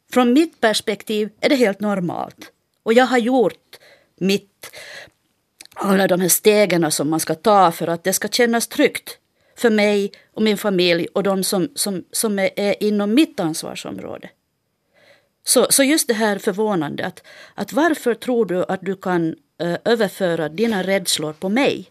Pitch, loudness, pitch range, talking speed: 200 Hz, -18 LUFS, 180-225 Hz, 165 wpm